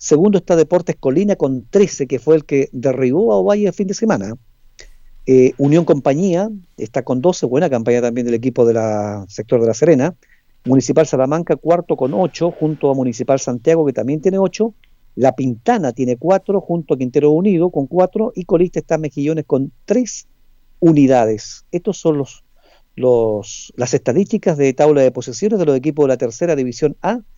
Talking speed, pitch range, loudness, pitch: 180 wpm, 130-180 Hz, -16 LUFS, 150 Hz